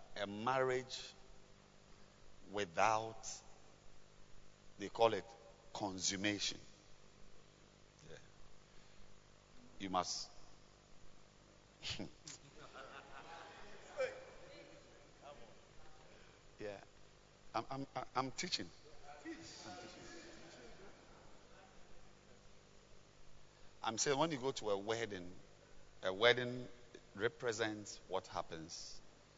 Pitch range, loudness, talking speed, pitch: 100-130 Hz, -41 LUFS, 55 wpm, 115 Hz